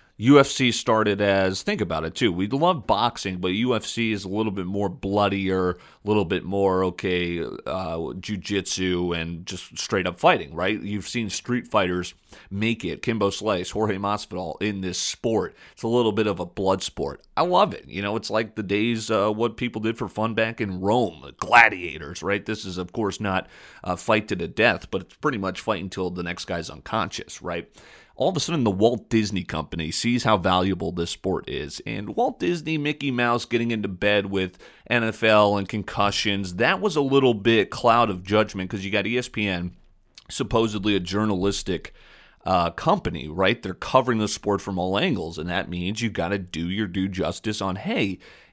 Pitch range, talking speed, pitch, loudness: 95-110 Hz, 195 wpm, 100 Hz, -24 LUFS